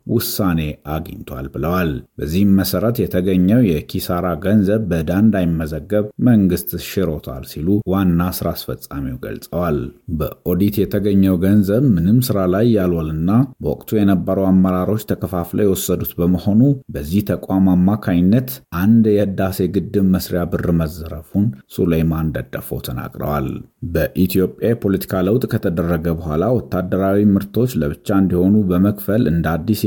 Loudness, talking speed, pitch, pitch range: -17 LUFS, 110 wpm, 95 Hz, 85-105 Hz